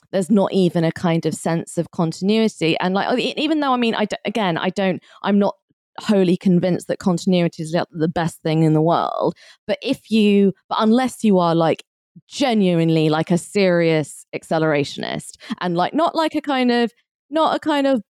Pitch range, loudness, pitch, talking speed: 165-225 Hz, -19 LUFS, 190 Hz, 190 wpm